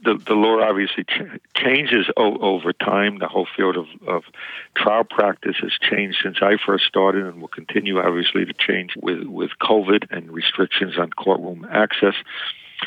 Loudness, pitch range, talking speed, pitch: -20 LUFS, 95-105 Hz, 170 wpm, 100 Hz